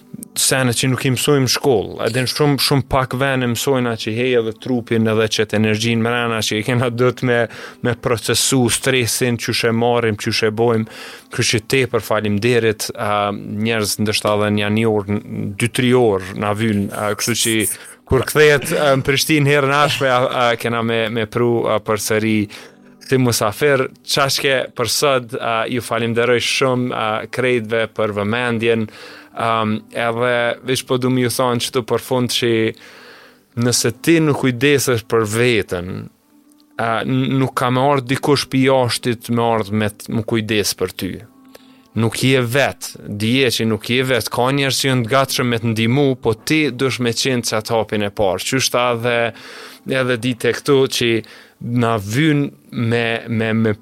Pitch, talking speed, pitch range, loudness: 120 Hz, 170 wpm, 110-130 Hz, -17 LUFS